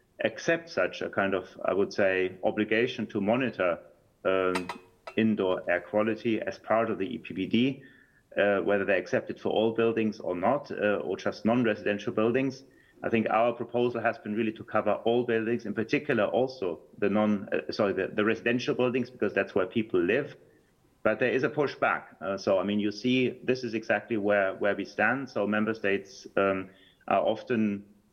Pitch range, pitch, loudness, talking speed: 105-120 Hz, 110 Hz, -28 LUFS, 185 wpm